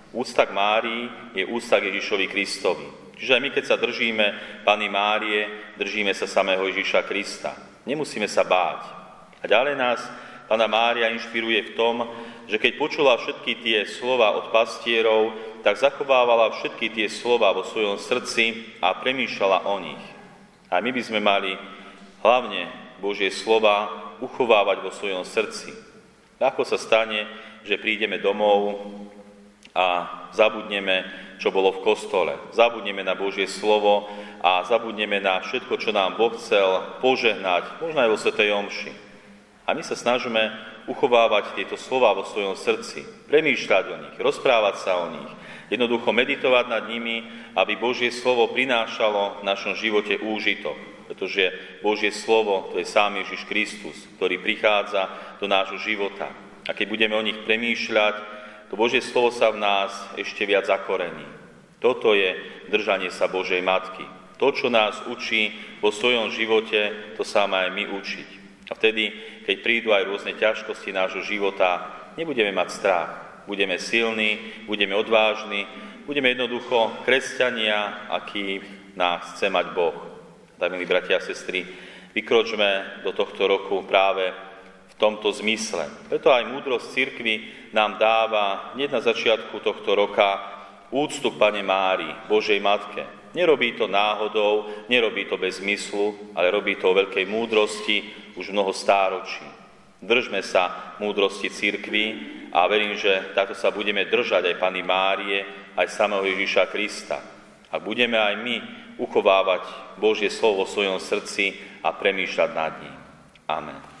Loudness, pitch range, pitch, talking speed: -23 LUFS, 100-115 Hz, 105 Hz, 140 wpm